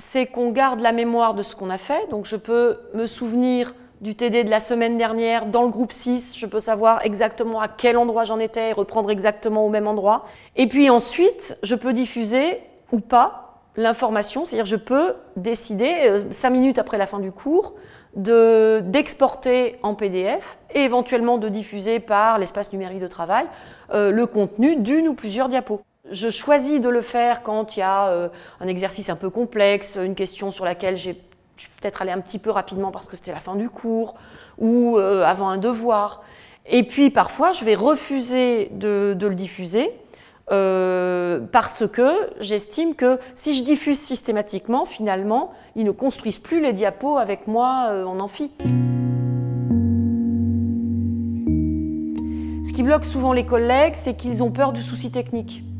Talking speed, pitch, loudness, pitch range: 175 wpm, 220 Hz, -21 LUFS, 195-245 Hz